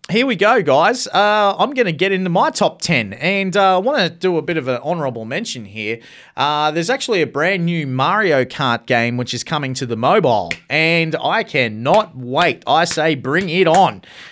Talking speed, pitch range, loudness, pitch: 210 wpm, 130-190 Hz, -16 LUFS, 160 Hz